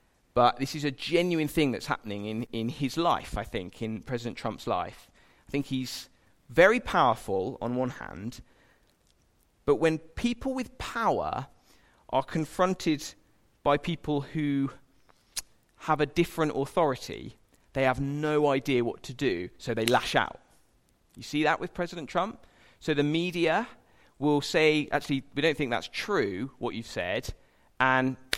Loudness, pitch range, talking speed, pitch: -29 LUFS, 120-155 Hz, 150 wpm, 140 Hz